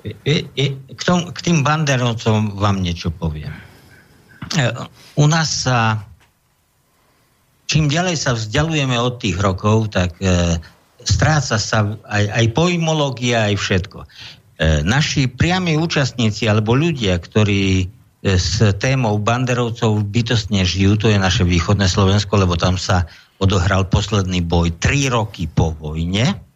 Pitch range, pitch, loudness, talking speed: 95-130 Hz, 110 Hz, -17 LUFS, 120 wpm